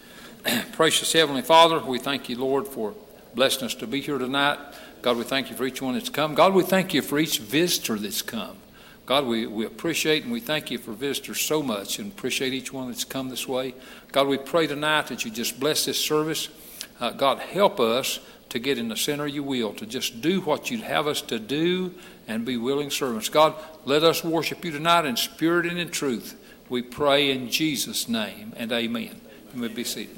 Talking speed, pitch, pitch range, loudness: 215 wpm, 145 Hz, 130-165 Hz, -24 LUFS